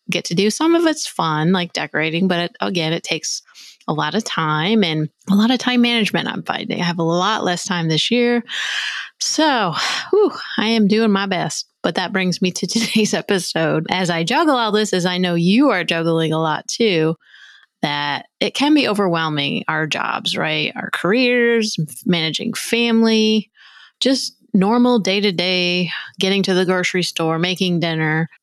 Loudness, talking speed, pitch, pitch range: -18 LUFS, 180 wpm, 190 Hz, 170-225 Hz